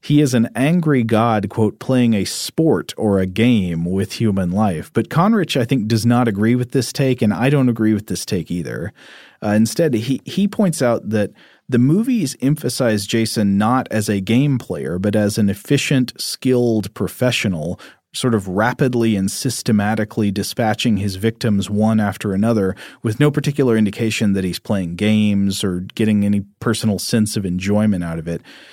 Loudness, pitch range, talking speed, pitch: -18 LUFS, 100-125 Hz, 180 wpm, 110 Hz